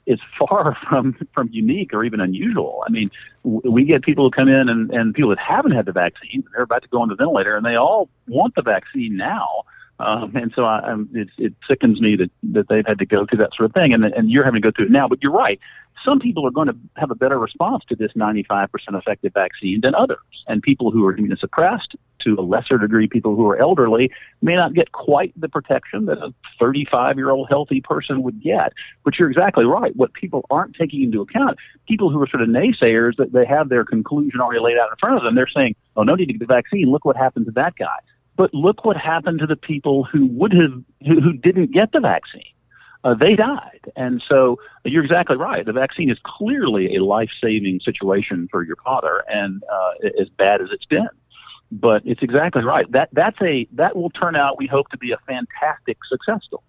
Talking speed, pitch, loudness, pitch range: 235 wpm, 135 Hz, -18 LUFS, 115-175 Hz